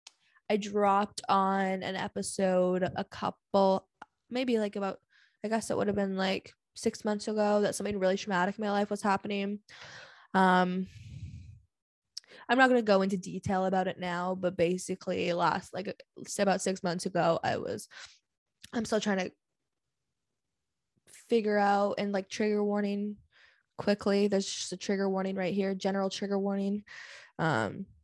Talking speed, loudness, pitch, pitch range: 155 wpm, -30 LUFS, 195 Hz, 190-205 Hz